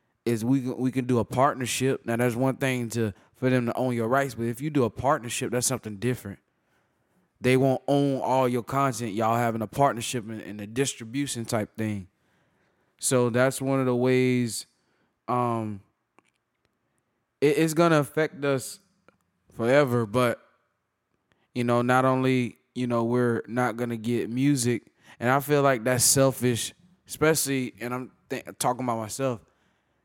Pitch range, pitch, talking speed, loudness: 115-135 Hz, 125 Hz, 160 wpm, -26 LUFS